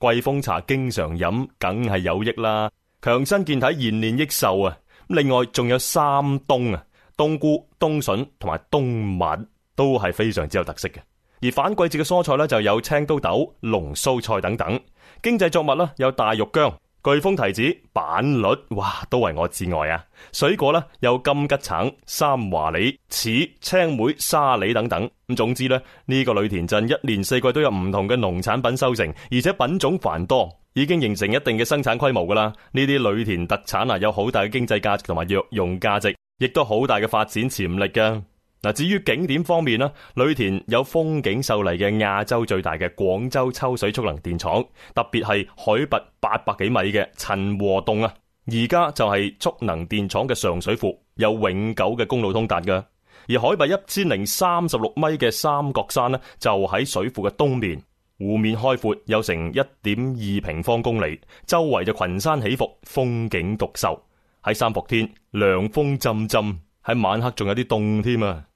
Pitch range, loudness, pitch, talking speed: 100-135 Hz, -22 LUFS, 115 Hz, 265 characters per minute